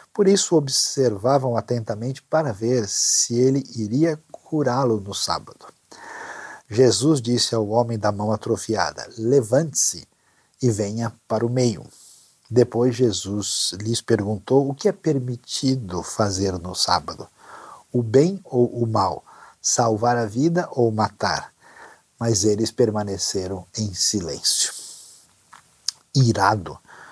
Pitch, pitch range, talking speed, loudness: 120 Hz, 110-130 Hz, 115 wpm, -21 LUFS